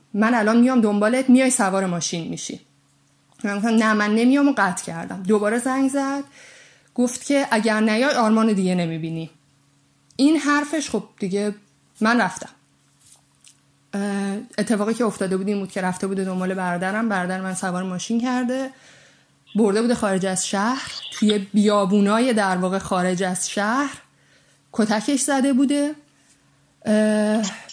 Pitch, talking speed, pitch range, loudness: 215 Hz, 140 wpm, 195-250 Hz, -21 LUFS